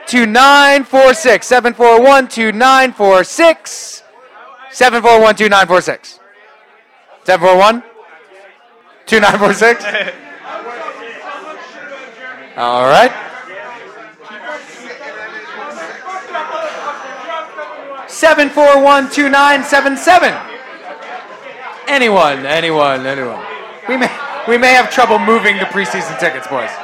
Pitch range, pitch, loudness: 210-280 Hz, 250 Hz, -10 LUFS